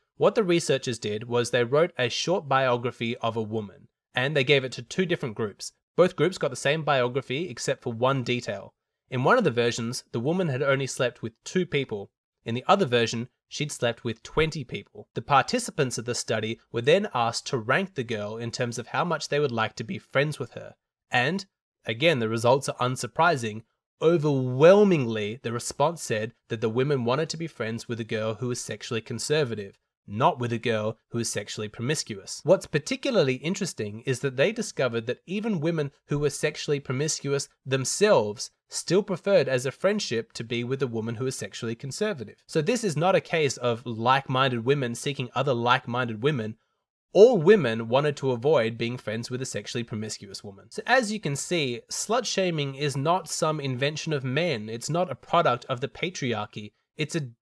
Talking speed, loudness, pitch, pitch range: 195 wpm, -26 LUFS, 130 Hz, 115-155 Hz